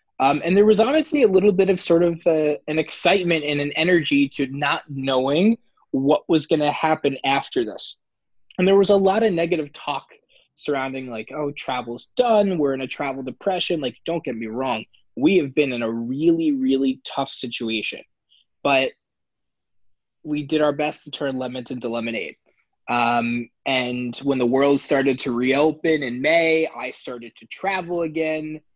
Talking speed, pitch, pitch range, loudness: 175 wpm, 145 Hz, 130-170 Hz, -21 LUFS